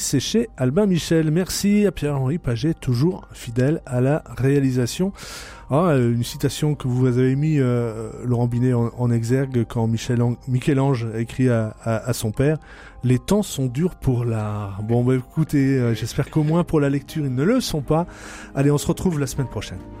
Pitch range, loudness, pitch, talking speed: 120-155 Hz, -21 LUFS, 130 Hz, 185 wpm